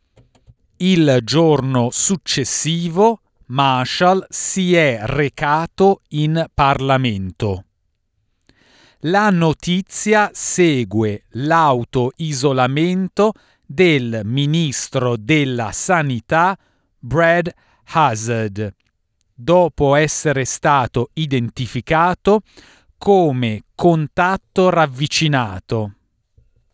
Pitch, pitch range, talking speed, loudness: 140 Hz, 120-170 Hz, 60 wpm, -17 LUFS